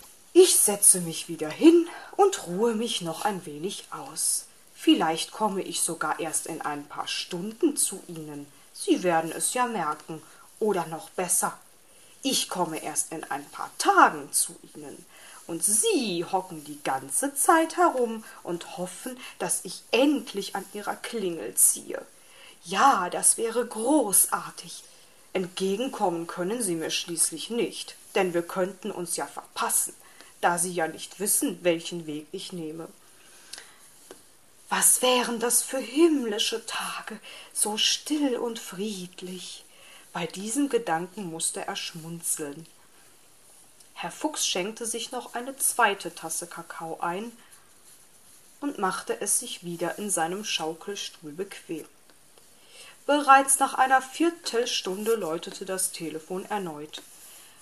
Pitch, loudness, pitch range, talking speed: 200 Hz, -25 LUFS, 170-245 Hz, 130 wpm